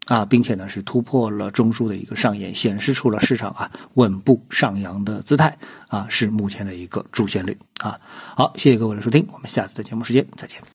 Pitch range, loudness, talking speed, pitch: 105-125 Hz, -21 LUFS, 330 characters per minute, 115 Hz